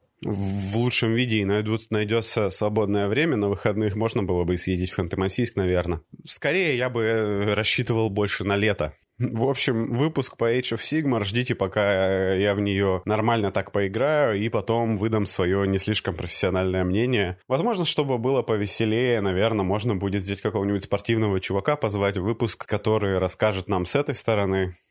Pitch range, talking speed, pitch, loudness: 95-115 Hz, 155 wpm, 105 Hz, -24 LUFS